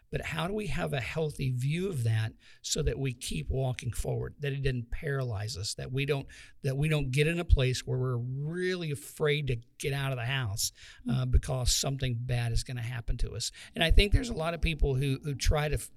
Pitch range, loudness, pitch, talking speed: 120-145 Hz, -31 LUFS, 135 Hz, 240 wpm